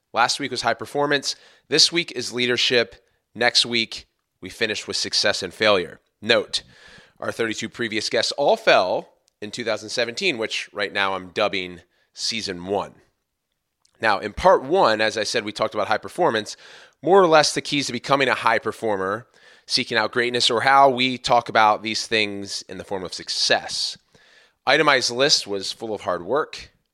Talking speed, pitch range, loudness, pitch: 170 wpm, 105-130 Hz, -21 LUFS, 115 Hz